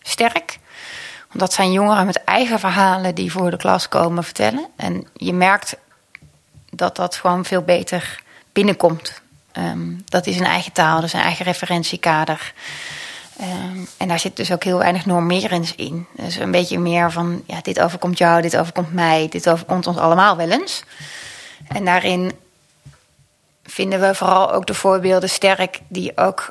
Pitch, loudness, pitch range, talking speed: 180 Hz, -18 LUFS, 170-190 Hz, 165 wpm